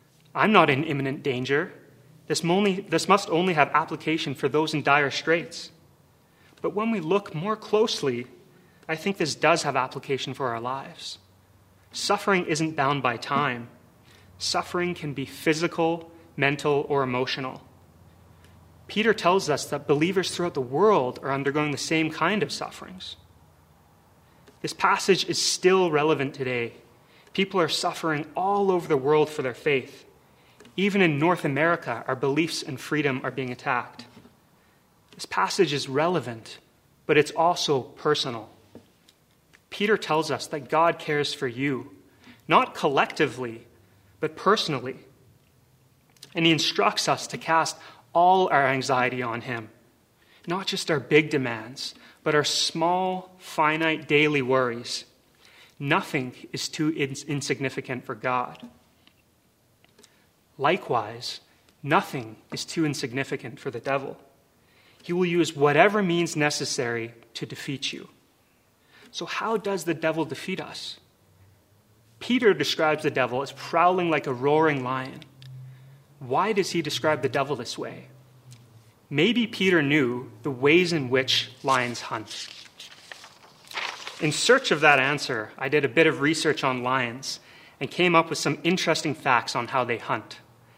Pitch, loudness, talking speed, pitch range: 145 Hz, -25 LUFS, 135 wpm, 125-165 Hz